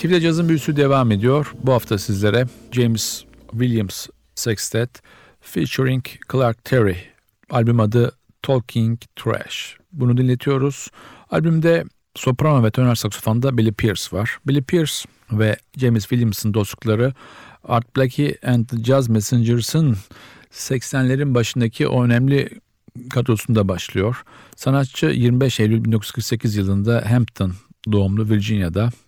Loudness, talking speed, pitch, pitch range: -19 LUFS, 110 wpm, 120 Hz, 110-130 Hz